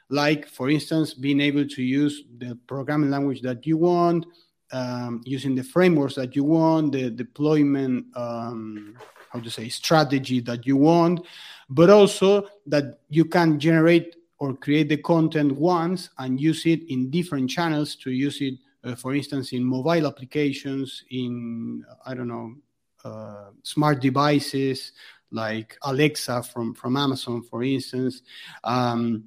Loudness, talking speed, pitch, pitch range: -23 LUFS, 145 wpm, 140 Hz, 125-155 Hz